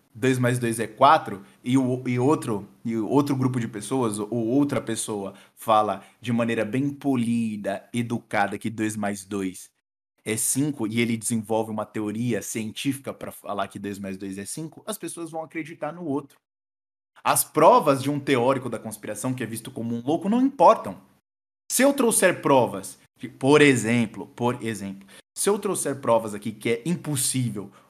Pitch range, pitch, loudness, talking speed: 105-140 Hz, 115 Hz, -24 LUFS, 170 wpm